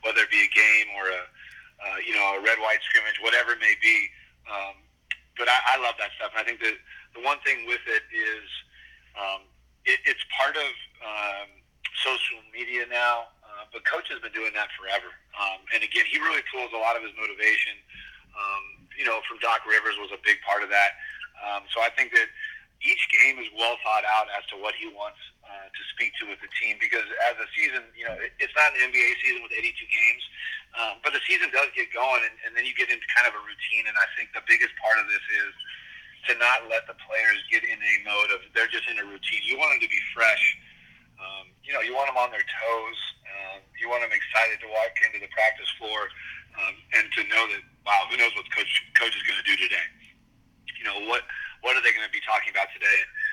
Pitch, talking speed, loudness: 355 Hz, 235 wpm, -24 LUFS